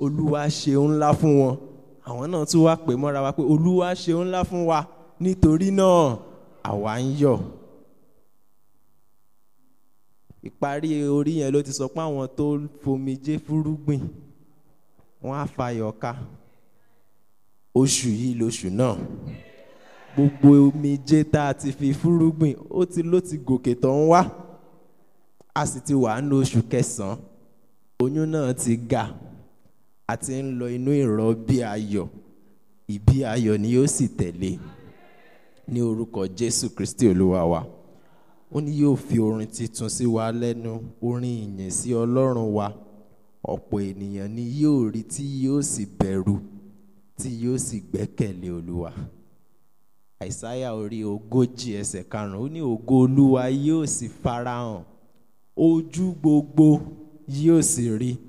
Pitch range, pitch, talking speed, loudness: 115-150 Hz, 130 Hz, 145 wpm, -23 LUFS